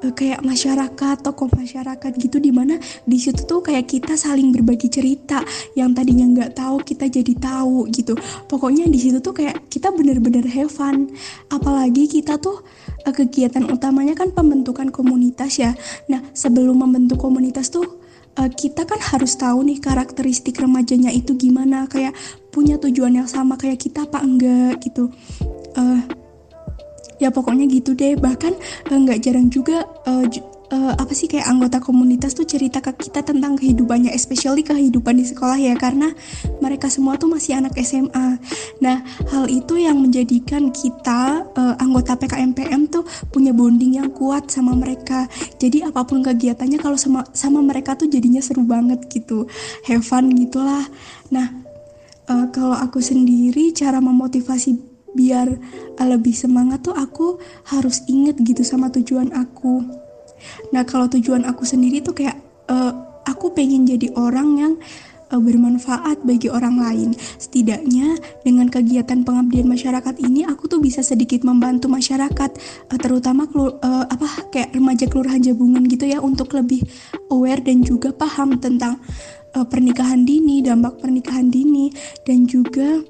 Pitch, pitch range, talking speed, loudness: 260 Hz, 250-280 Hz, 145 wpm, -17 LUFS